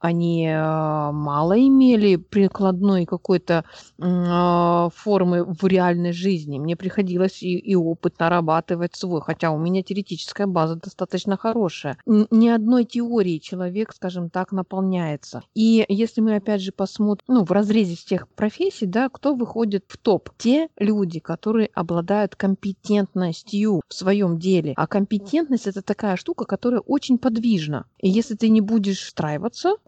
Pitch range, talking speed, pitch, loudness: 175-215 Hz, 135 wpm, 190 Hz, -21 LUFS